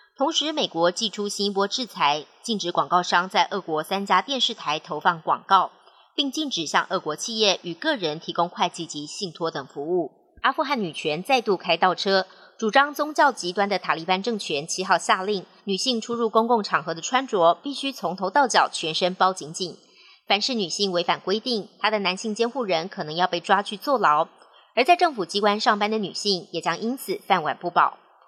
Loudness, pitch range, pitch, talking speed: -23 LUFS, 175-235 Hz, 195 Hz, 295 characters per minute